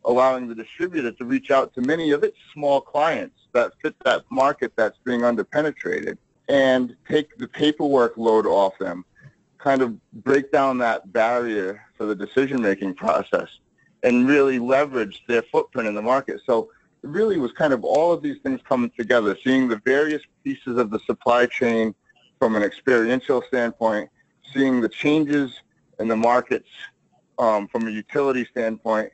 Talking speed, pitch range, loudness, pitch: 165 wpm, 115-145 Hz, -22 LUFS, 130 Hz